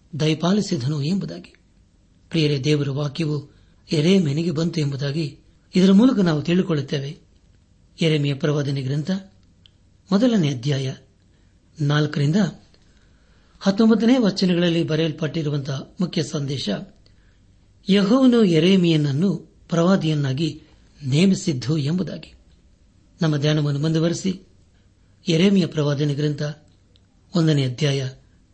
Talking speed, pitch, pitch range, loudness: 75 wpm, 150 Hz, 105-170 Hz, -21 LUFS